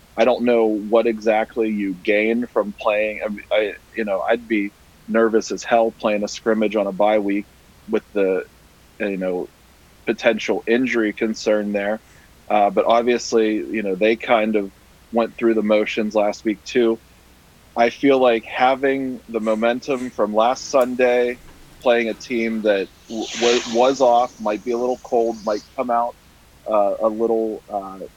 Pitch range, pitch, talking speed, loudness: 105-120 Hz, 115 Hz, 160 wpm, -20 LUFS